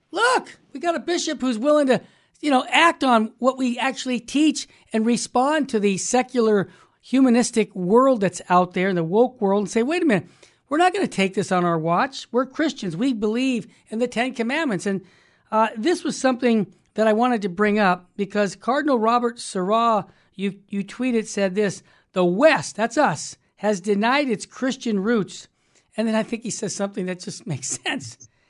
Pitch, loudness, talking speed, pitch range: 225 Hz, -22 LUFS, 195 wpm, 195-260 Hz